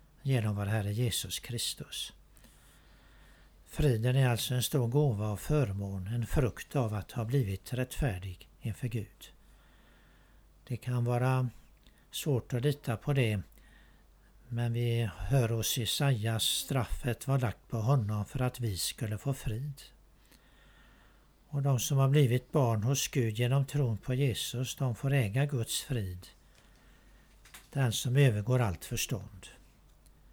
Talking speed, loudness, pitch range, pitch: 135 wpm, -32 LUFS, 110-135 Hz, 125 Hz